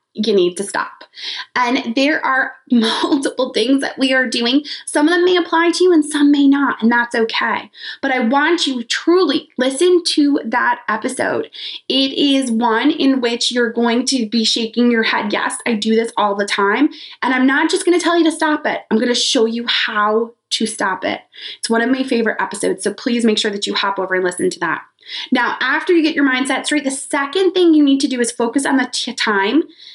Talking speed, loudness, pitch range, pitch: 225 wpm, -16 LUFS, 235-310 Hz, 265 Hz